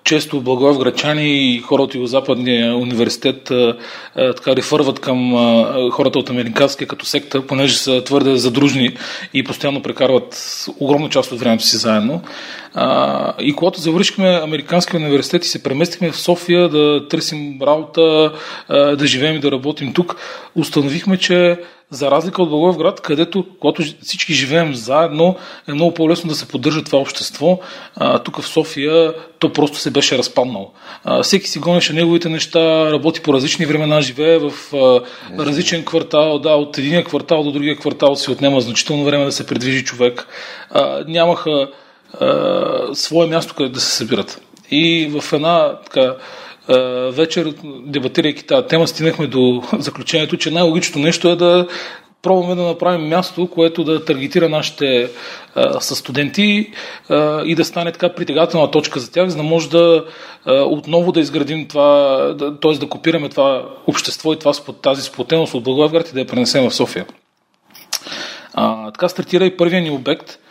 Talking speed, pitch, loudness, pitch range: 155 wpm, 155 Hz, -15 LUFS, 140-170 Hz